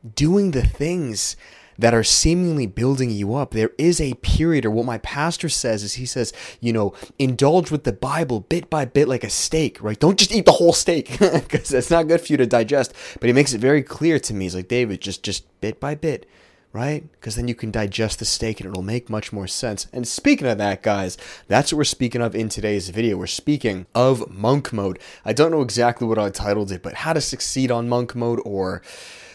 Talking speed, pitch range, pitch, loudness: 230 wpm, 105-150 Hz, 120 Hz, -20 LUFS